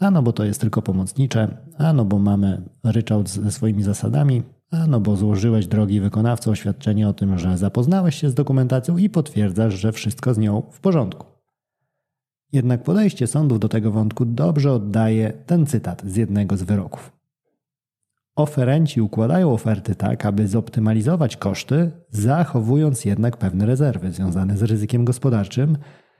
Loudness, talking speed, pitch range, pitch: -20 LUFS, 150 wpm, 105-140 Hz, 115 Hz